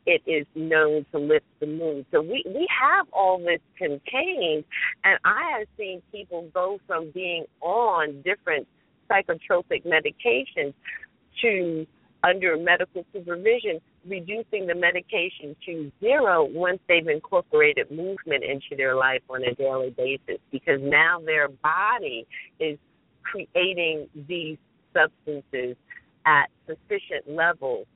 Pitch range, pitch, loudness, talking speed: 150-225 Hz, 175 Hz, -24 LUFS, 120 wpm